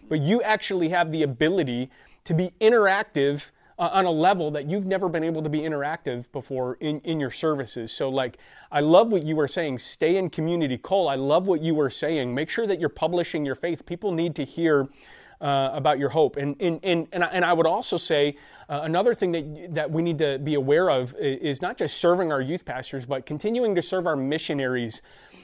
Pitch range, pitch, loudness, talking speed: 140-175 Hz, 155 Hz, -24 LUFS, 215 wpm